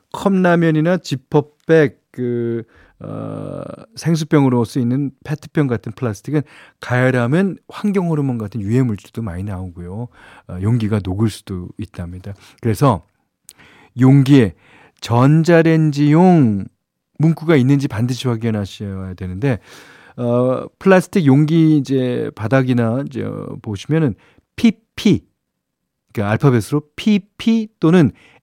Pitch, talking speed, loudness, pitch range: 130 Hz, 265 characters per minute, -17 LUFS, 110-155 Hz